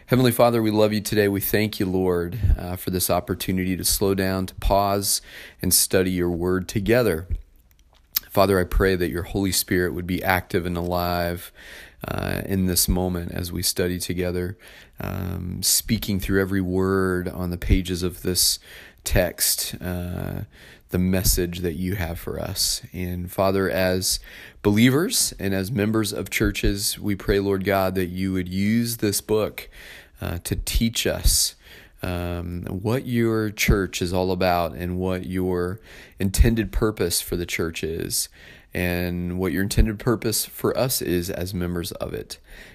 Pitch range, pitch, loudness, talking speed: 90-100 Hz, 95 Hz, -23 LUFS, 160 wpm